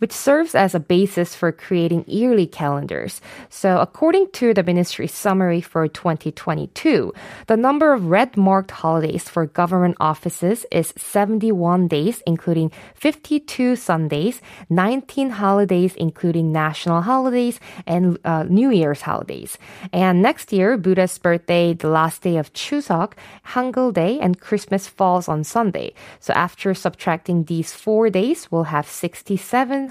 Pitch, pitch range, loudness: 185 Hz, 170-220 Hz, -19 LUFS